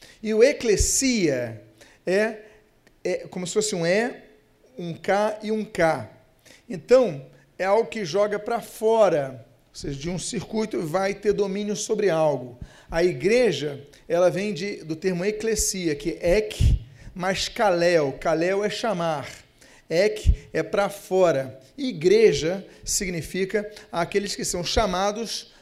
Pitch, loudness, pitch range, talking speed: 190 Hz, -24 LUFS, 160-215 Hz, 135 wpm